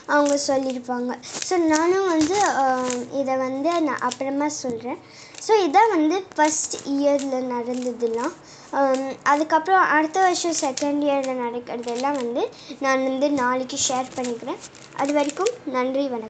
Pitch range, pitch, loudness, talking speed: 255-315 Hz, 275 Hz, -22 LUFS, 120 wpm